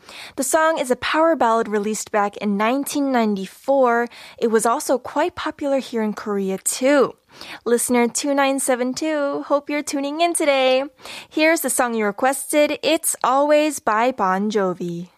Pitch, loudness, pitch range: 260 Hz, -20 LUFS, 220-290 Hz